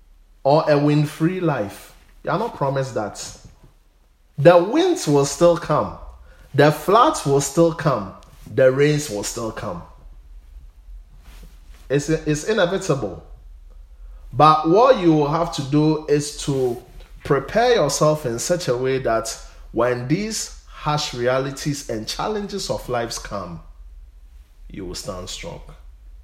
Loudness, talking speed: -20 LUFS, 130 wpm